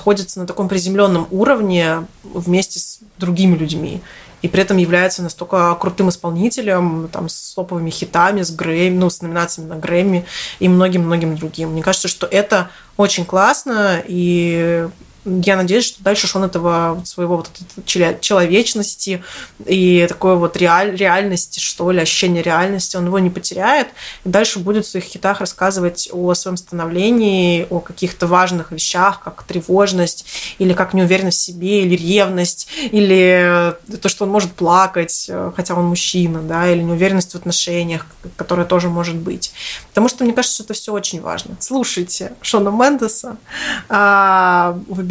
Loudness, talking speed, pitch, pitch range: -15 LUFS, 155 wpm, 180 Hz, 175-195 Hz